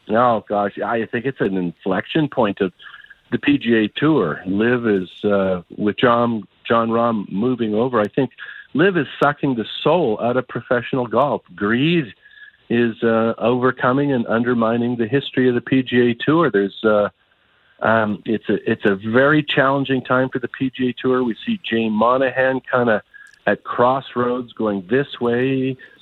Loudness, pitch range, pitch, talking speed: -19 LUFS, 110-130 Hz, 120 Hz, 155 wpm